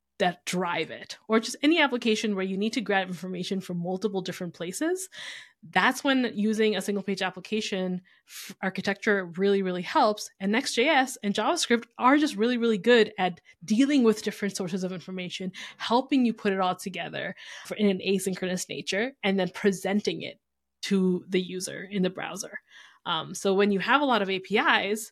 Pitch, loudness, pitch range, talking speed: 200 Hz, -27 LUFS, 185-225 Hz, 175 wpm